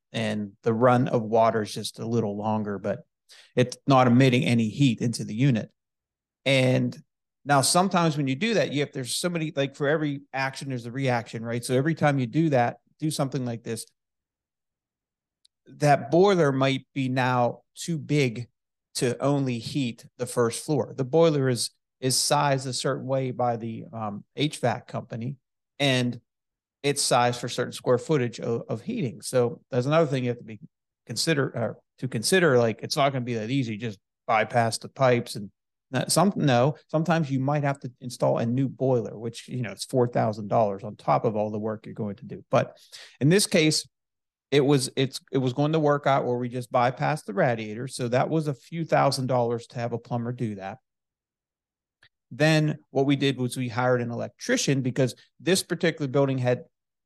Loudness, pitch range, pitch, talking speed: -25 LUFS, 120-145 Hz, 130 Hz, 190 wpm